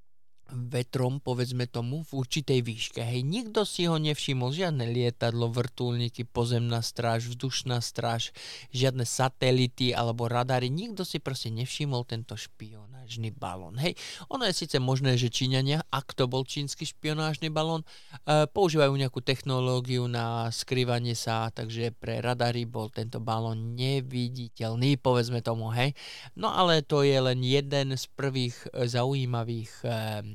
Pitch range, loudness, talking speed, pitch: 115-135 Hz, -29 LUFS, 135 wpm, 125 Hz